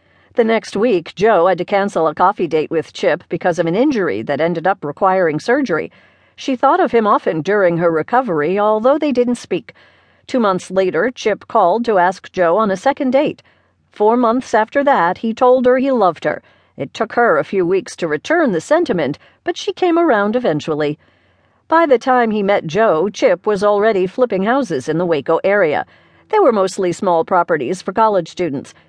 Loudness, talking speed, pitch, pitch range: -16 LUFS, 195 wpm, 205 Hz, 175-250 Hz